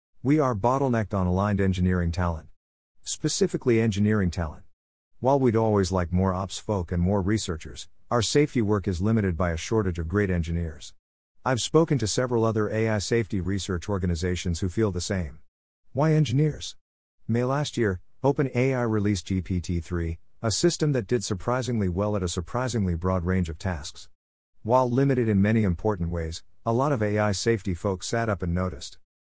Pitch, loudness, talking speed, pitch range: 100 Hz, -26 LUFS, 165 wpm, 90-115 Hz